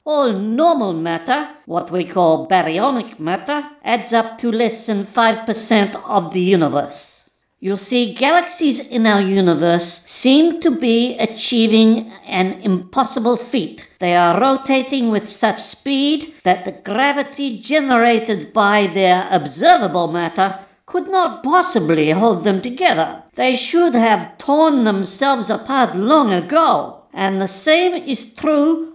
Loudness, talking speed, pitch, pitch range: -16 LUFS, 135 wpm, 225 Hz, 195-275 Hz